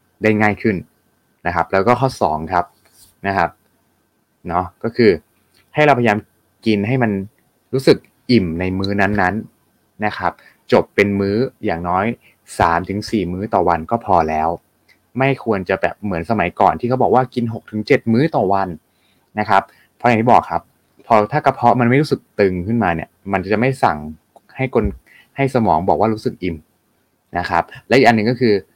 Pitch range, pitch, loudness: 90-120 Hz, 105 Hz, -17 LUFS